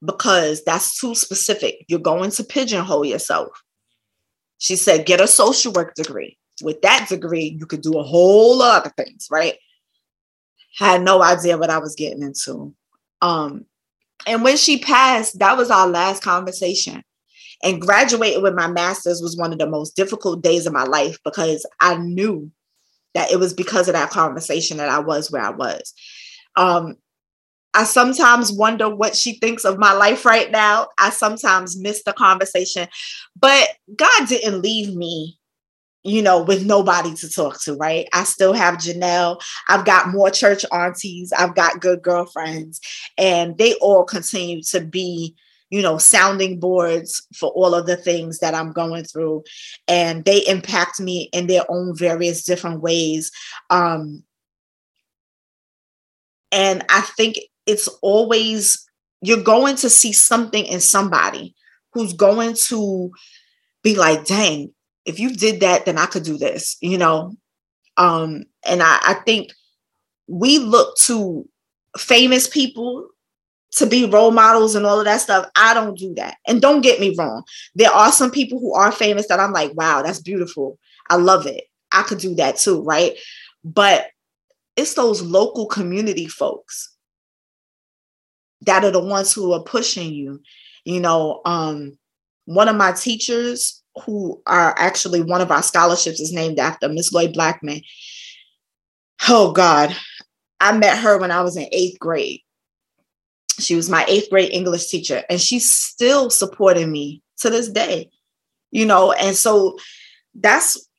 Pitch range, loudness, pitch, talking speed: 170-220 Hz, -16 LUFS, 185 Hz, 160 wpm